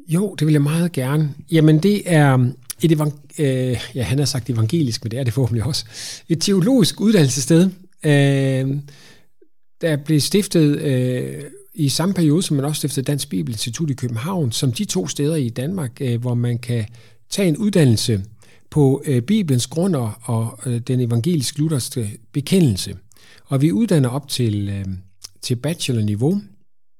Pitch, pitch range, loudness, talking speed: 140 Hz, 120-160 Hz, -19 LUFS, 165 wpm